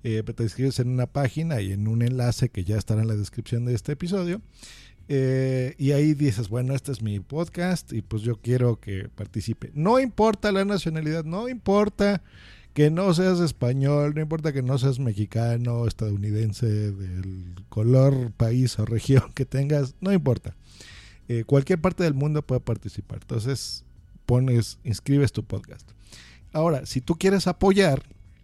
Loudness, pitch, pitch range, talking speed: -25 LUFS, 125 Hz, 110-155 Hz, 160 wpm